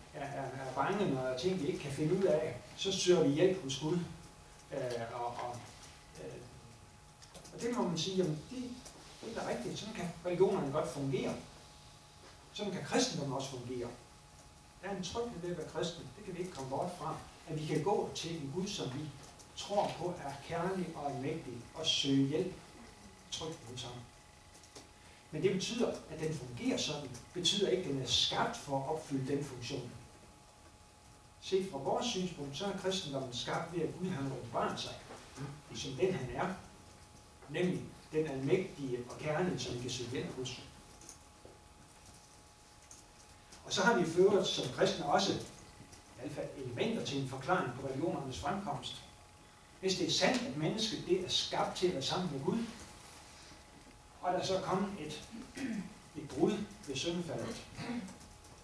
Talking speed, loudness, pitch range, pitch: 170 wpm, -36 LUFS, 130-185 Hz, 155 Hz